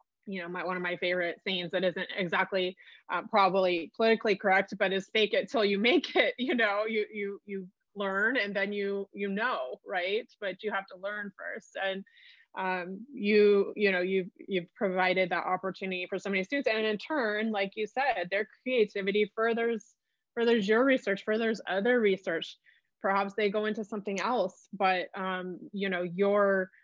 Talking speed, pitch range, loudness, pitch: 180 wpm, 190-215 Hz, -30 LUFS, 200 Hz